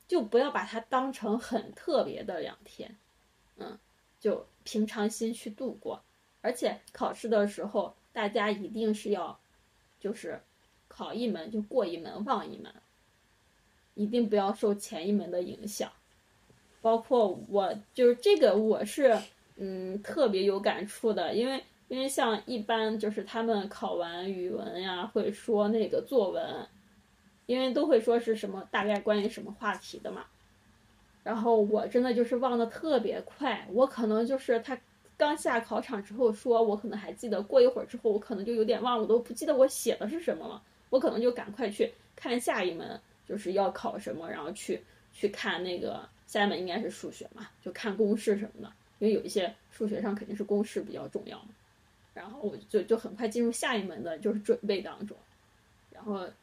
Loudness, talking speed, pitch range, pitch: -31 LUFS, 265 characters per minute, 205-240 Hz, 220 Hz